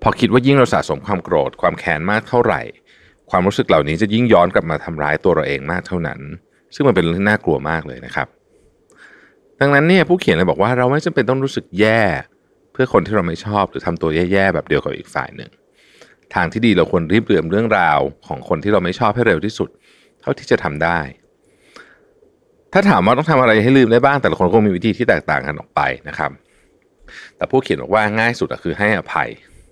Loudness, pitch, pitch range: -16 LUFS, 120 Hz, 90-145 Hz